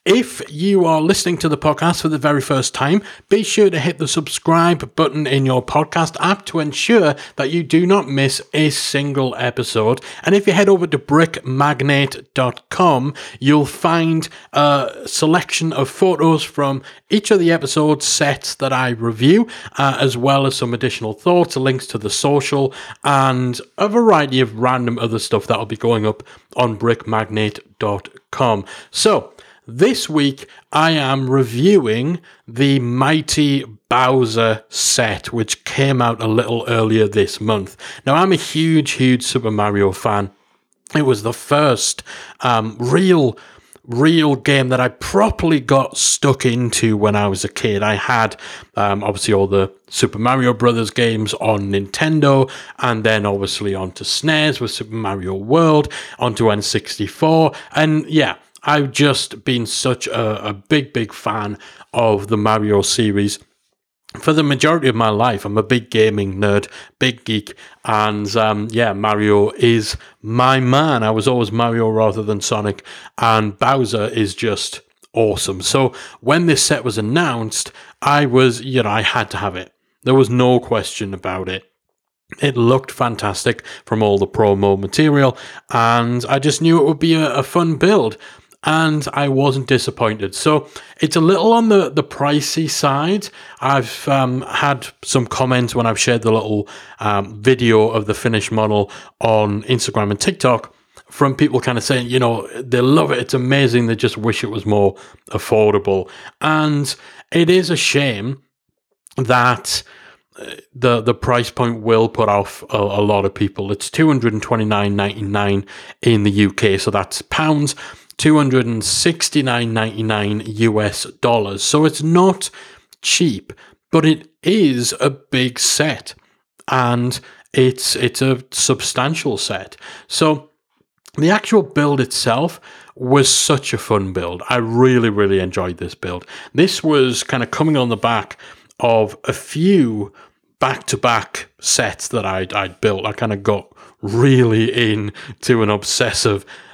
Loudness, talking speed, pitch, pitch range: -16 LUFS, 155 wpm, 125 Hz, 110-150 Hz